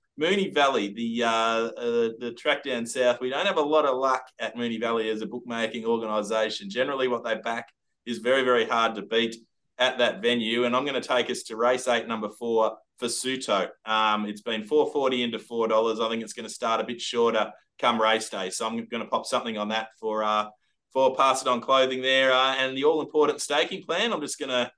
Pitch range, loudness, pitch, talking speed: 110-130 Hz, -25 LUFS, 115 Hz, 225 wpm